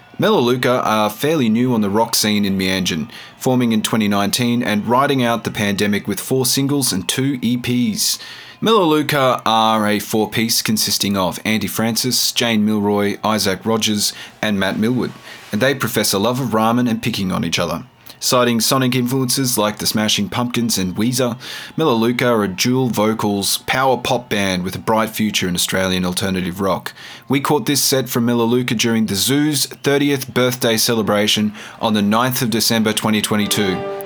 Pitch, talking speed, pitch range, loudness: 115 Hz, 165 wpm, 105-125 Hz, -17 LUFS